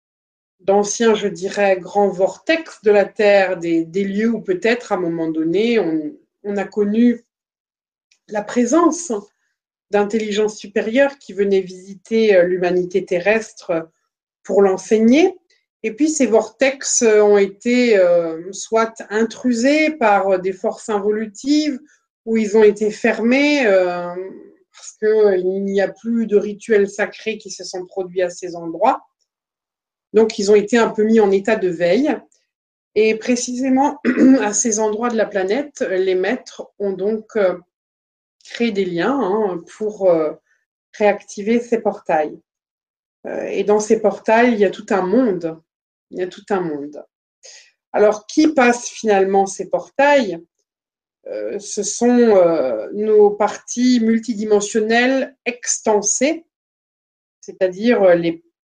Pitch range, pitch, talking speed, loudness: 195-240 Hz, 210 Hz, 130 wpm, -17 LUFS